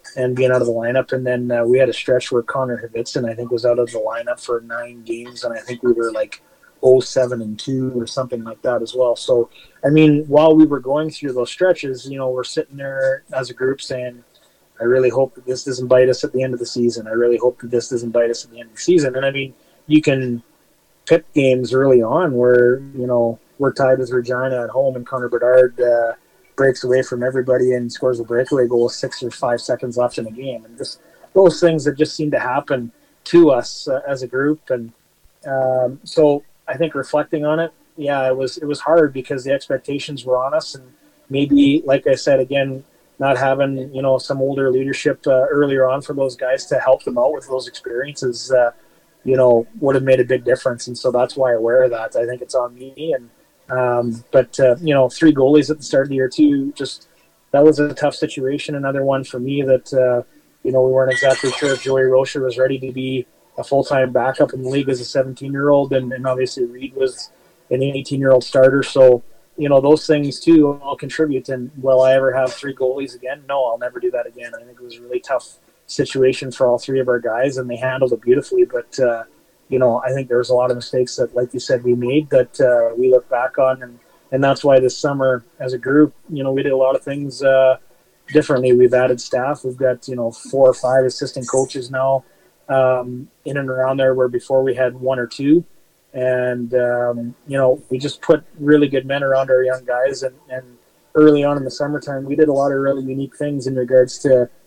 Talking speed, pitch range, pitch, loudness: 235 wpm, 125-140 Hz, 130 Hz, -17 LUFS